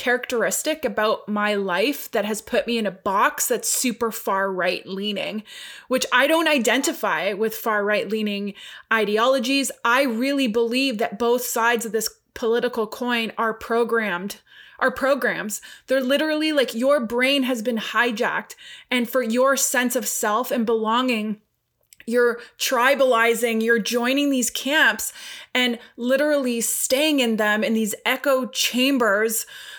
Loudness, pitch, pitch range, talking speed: -21 LUFS, 240 Hz, 220-265 Hz, 140 wpm